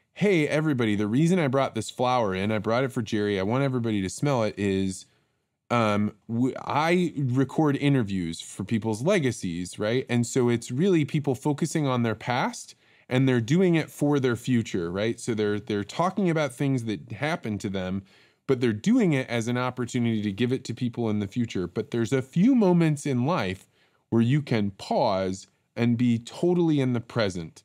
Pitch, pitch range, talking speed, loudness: 120 Hz, 105-140 Hz, 190 wpm, -26 LUFS